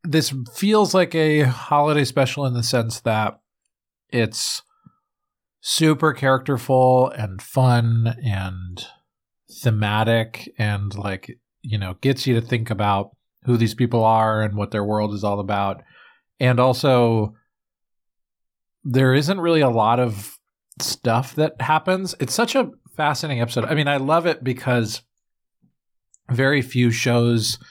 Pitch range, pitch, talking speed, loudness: 110-145 Hz, 125 Hz, 135 wpm, -20 LUFS